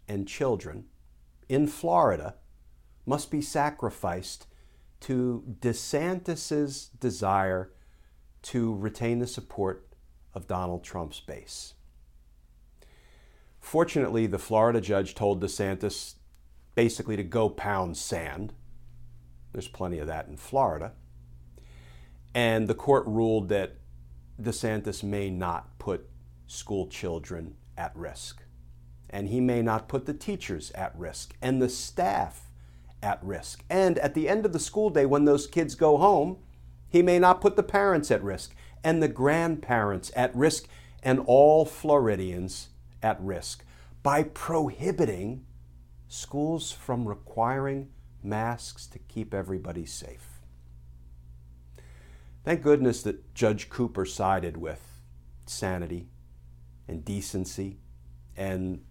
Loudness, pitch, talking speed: -28 LUFS, 95 Hz, 115 wpm